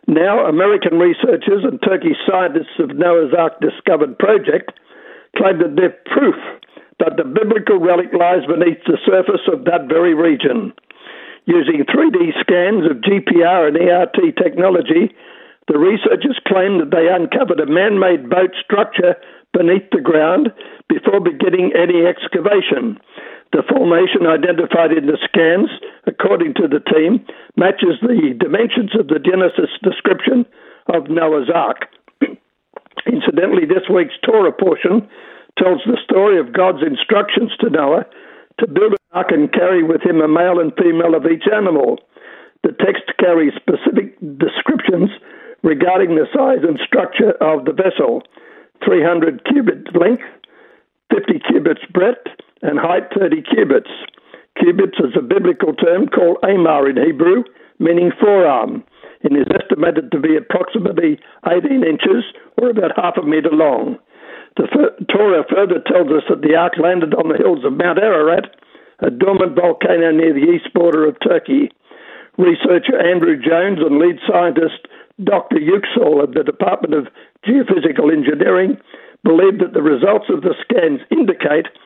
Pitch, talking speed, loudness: 195 Hz, 145 wpm, -14 LUFS